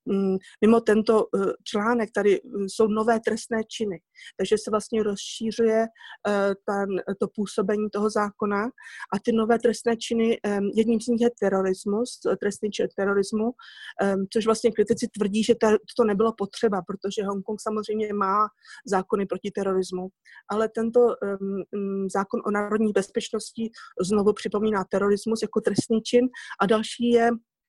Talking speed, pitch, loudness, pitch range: 130 wpm, 215 Hz, -25 LUFS, 200-225 Hz